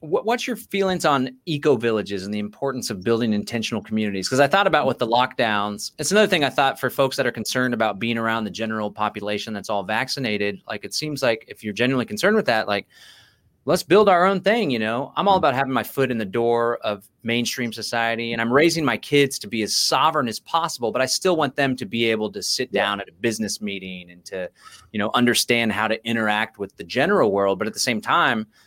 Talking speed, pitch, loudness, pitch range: 230 wpm, 115 Hz, -21 LUFS, 105-135 Hz